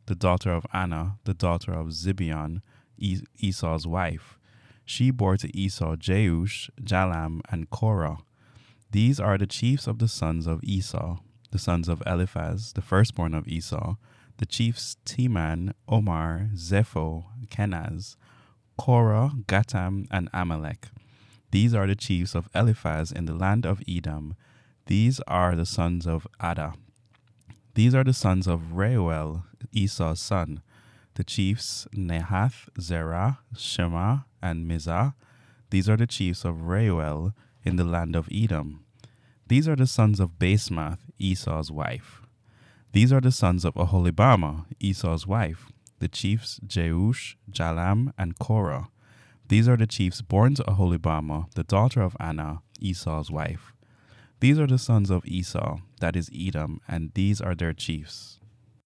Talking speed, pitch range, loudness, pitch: 140 wpm, 85-115 Hz, -26 LUFS, 100 Hz